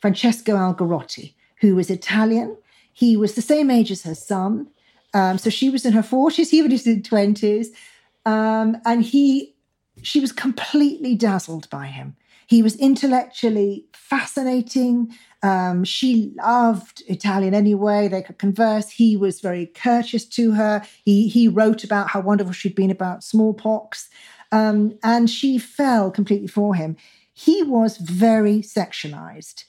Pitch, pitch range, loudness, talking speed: 220 Hz, 200-235 Hz, -19 LUFS, 150 wpm